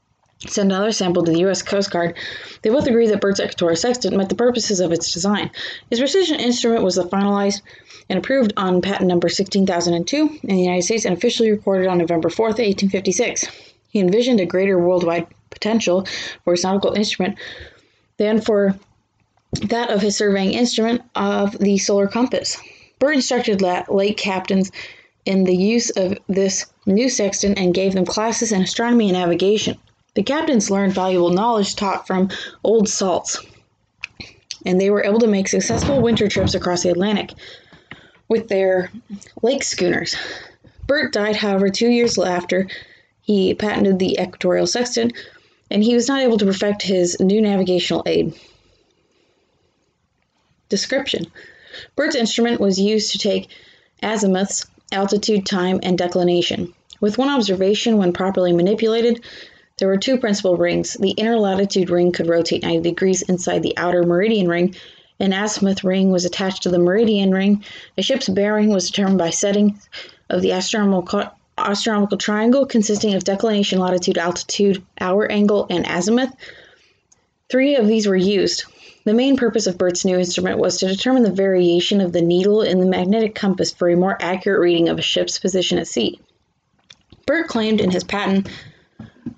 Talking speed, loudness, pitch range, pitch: 160 wpm, -18 LUFS, 185-220 Hz, 195 Hz